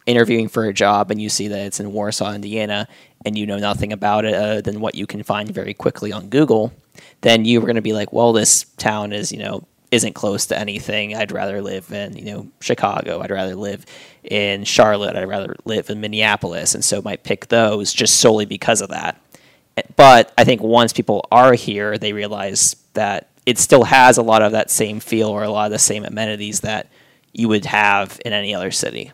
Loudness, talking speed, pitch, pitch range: -16 LUFS, 220 wpm, 105 Hz, 105-110 Hz